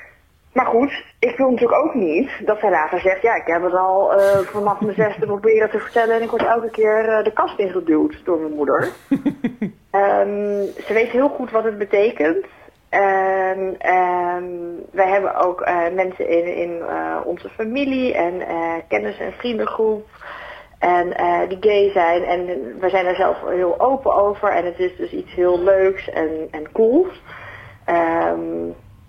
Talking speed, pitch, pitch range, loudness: 175 wpm, 190 Hz, 175-220 Hz, -19 LUFS